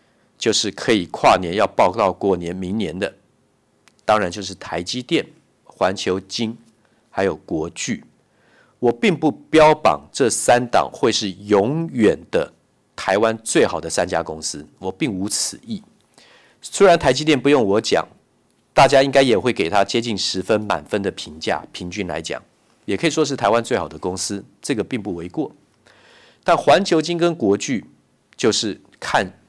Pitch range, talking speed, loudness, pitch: 95-155 Hz, 230 characters per minute, -19 LUFS, 115 Hz